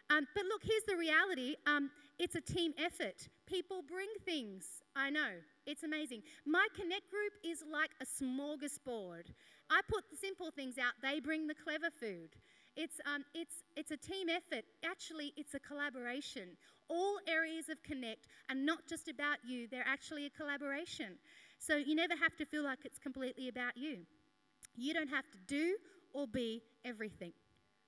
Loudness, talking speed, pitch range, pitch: -40 LUFS, 170 wpm, 265-335 Hz, 300 Hz